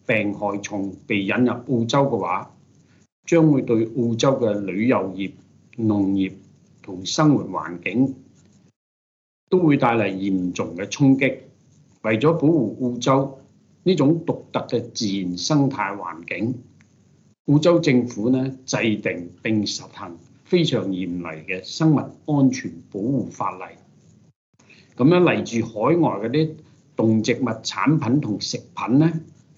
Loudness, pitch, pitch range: -21 LUFS, 125 Hz, 105-140 Hz